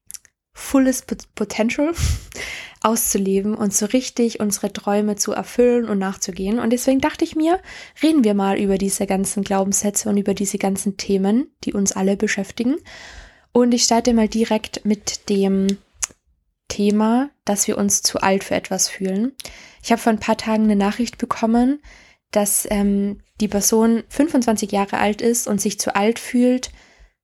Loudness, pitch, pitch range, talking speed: -19 LUFS, 215 Hz, 200-240 Hz, 155 wpm